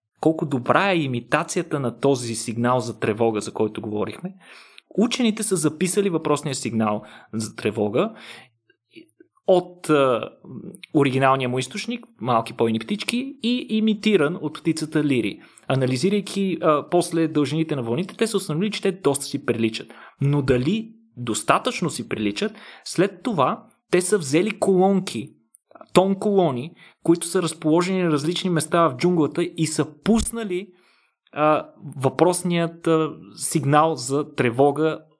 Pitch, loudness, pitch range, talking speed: 160 Hz, -22 LUFS, 135-190 Hz, 130 wpm